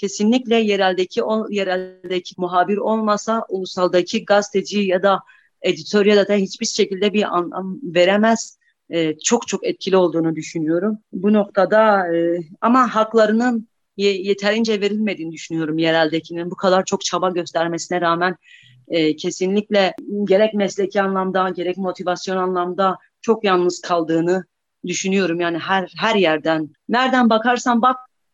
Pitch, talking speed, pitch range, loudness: 190 Hz, 125 wpm, 175-210 Hz, -19 LUFS